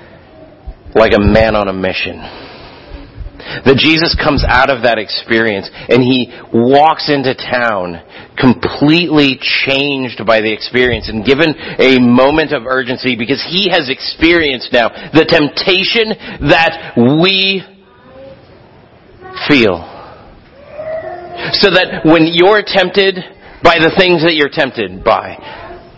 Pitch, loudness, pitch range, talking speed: 145 Hz, -11 LUFS, 120-180 Hz, 120 wpm